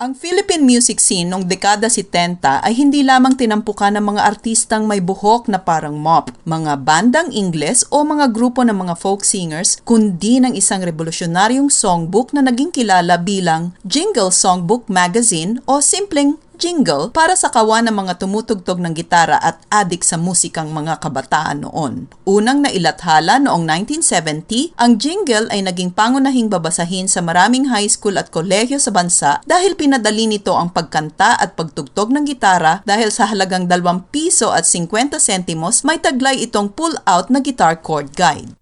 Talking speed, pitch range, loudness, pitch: 160 wpm, 180-255 Hz, -14 LUFS, 205 Hz